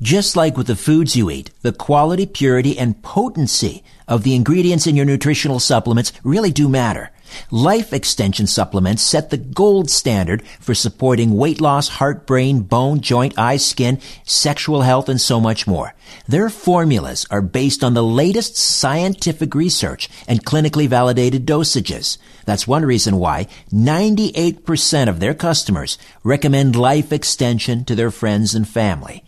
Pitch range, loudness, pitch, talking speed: 115-155 Hz, -16 LUFS, 130 Hz, 150 wpm